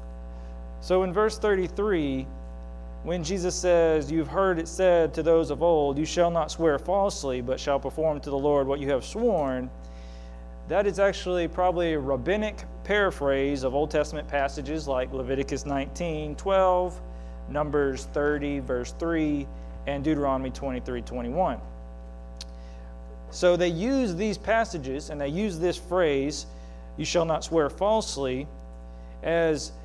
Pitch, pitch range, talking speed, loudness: 145 Hz, 125-175 Hz, 140 wpm, -26 LUFS